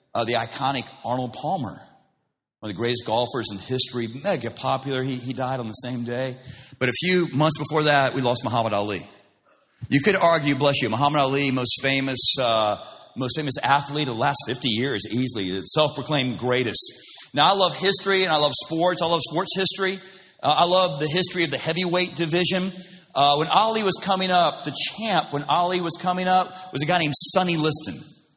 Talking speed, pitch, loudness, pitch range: 195 wpm, 145 Hz, -21 LUFS, 125-175 Hz